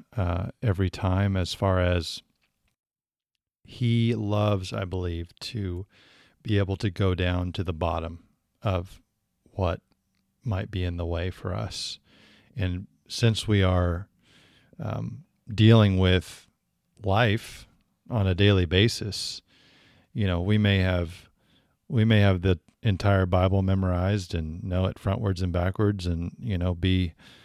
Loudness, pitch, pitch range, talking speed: -26 LUFS, 95 Hz, 90-105 Hz, 135 wpm